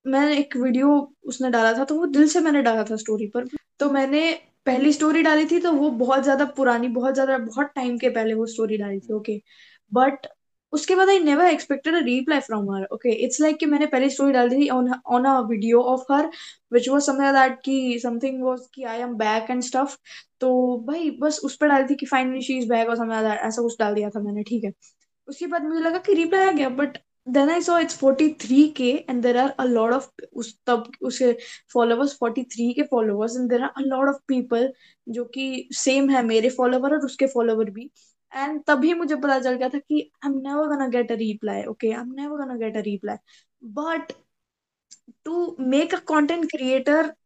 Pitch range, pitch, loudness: 240-295 Hz, 265 Hz, -22 LUFS